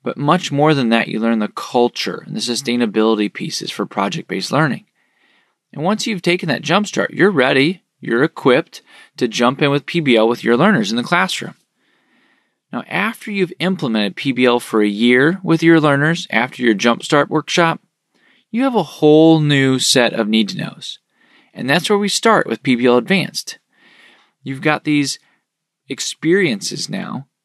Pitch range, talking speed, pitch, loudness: 120-180 Hz, 170 wpm, 145 Hz, -16 LUFS